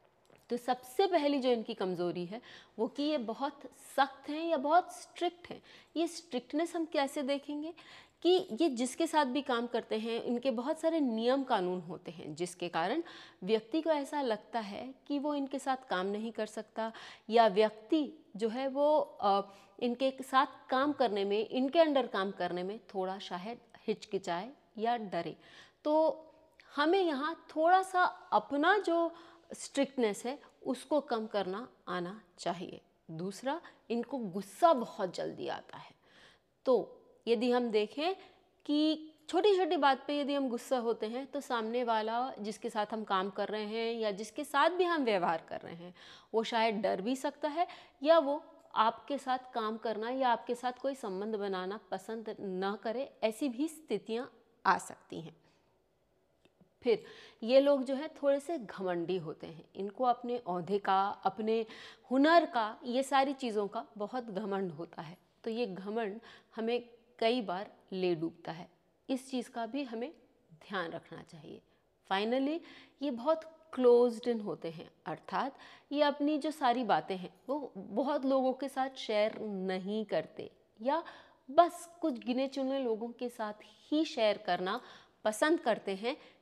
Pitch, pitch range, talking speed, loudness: 245 Hz, 210-290 Hz, 160 wpm, -34 LUFS